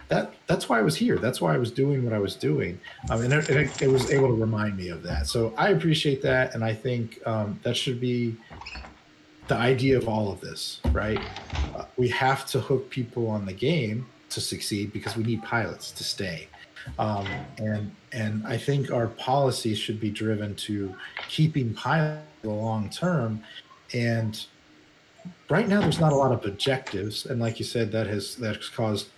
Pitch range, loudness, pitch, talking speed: 105-135 Hz, -27 LUFS, 115 Hz, 195 wpm